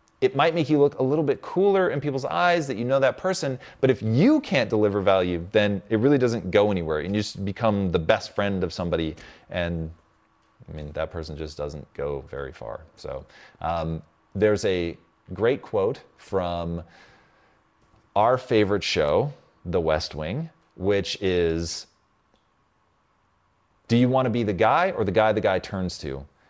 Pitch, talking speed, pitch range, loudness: 105 Hz, 175 wpm, 85-130 Hz, -24 LUFS